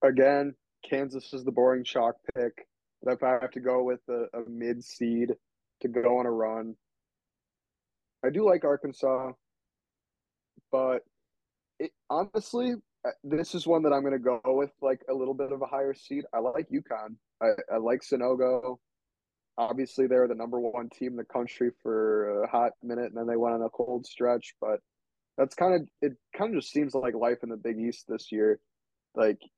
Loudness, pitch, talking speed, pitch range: -29 LUFS, 125 Hz, 190 wpm, 120-135 Hz